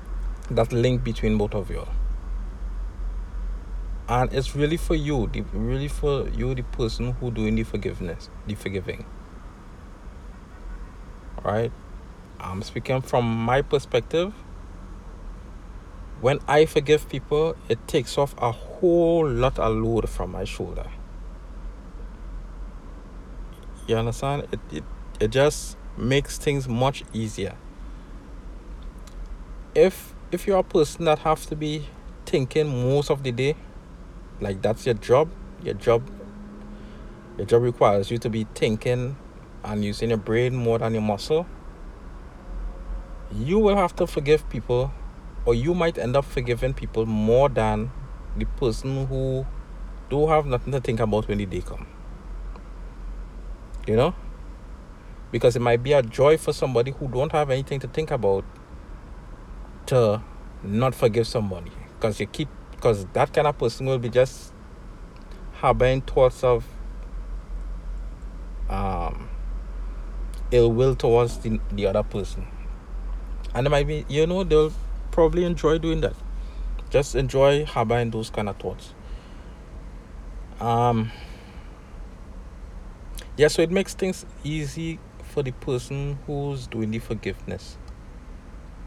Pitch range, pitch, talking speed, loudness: 95-140 Hz, 115 Hz, 130 wpm, -24 LUFS